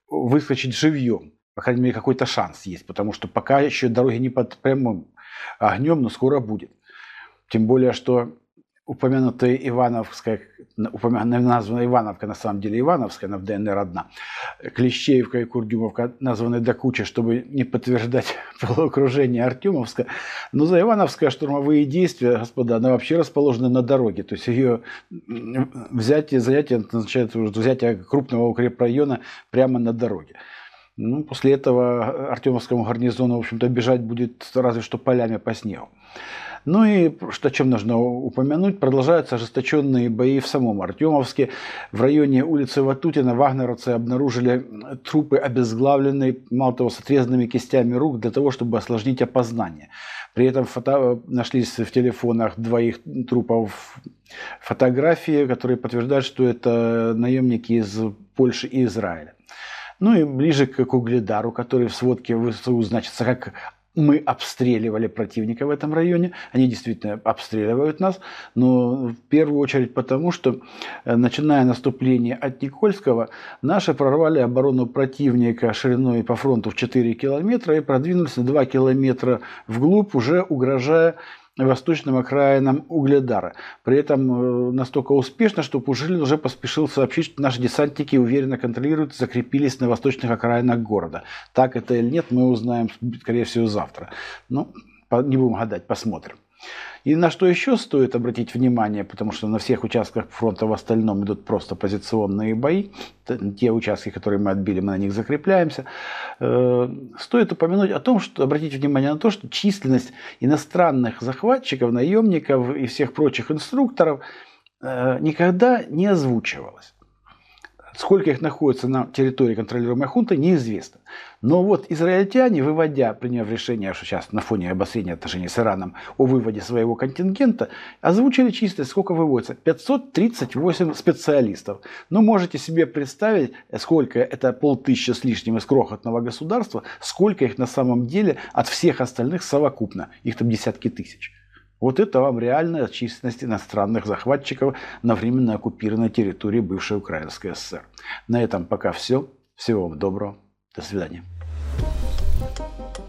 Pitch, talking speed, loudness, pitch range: 125 Hz, 140 wpm, -21 LUFS, 115-140 Hz